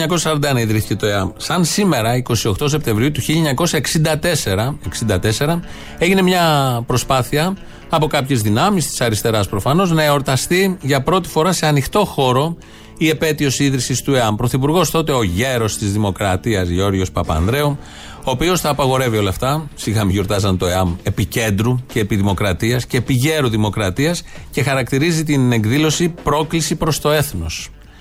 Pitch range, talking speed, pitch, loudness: 110-155 Hz, 135 wpm, 135 Hz, -17 LUFS